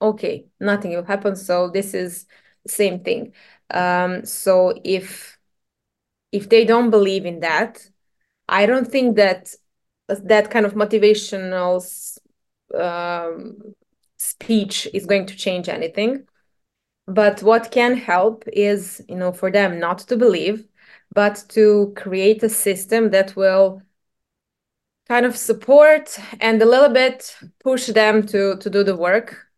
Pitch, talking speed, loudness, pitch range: 205 Hz, 135 wpm, -18 LUFS, 190-225 Hz